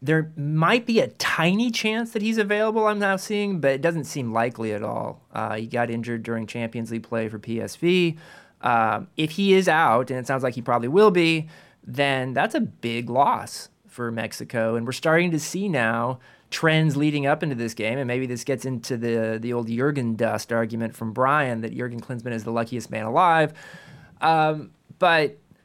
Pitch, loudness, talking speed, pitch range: 135 Hz, -23 LUFS, 195 wpm, 115-165 Hz